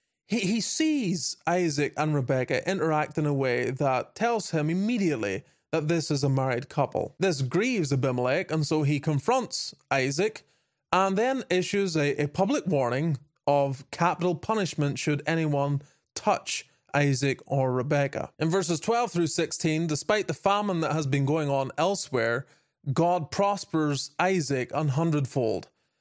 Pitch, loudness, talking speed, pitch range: 155 Hz, -27 LUFS, 140 wpm, 140-180 Hz